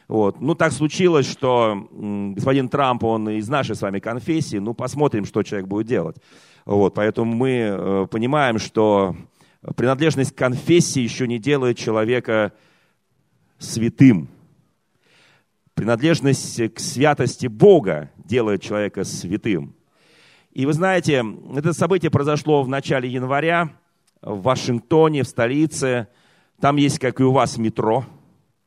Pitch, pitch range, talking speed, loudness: 130 Hz, 110-150 Hz, 125 wpm, -20 LUFS